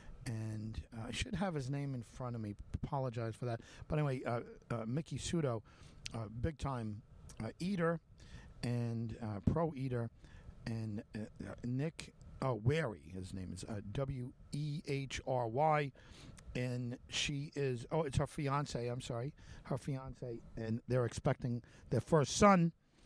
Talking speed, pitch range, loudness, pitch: 160 wpm, 110-140 Hz, -39 LUFS, 125 Hz